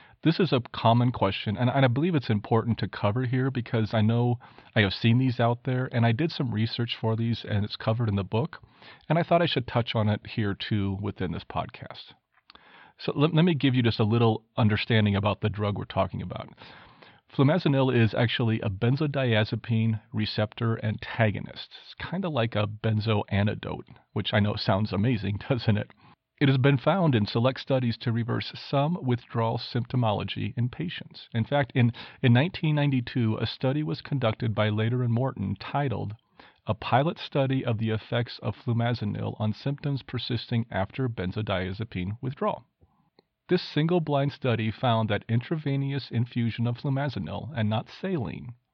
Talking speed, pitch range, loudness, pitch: 175 wpm, 110-135 Hz, -27 LUFS, 115 Hz